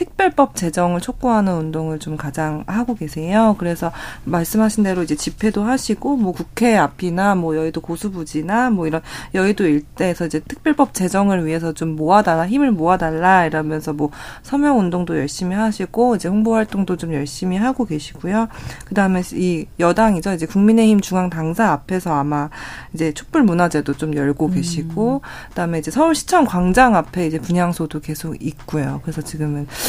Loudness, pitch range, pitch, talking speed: -18 LUFS, 155-215 Hz, 175 Hz, 375 characters per minute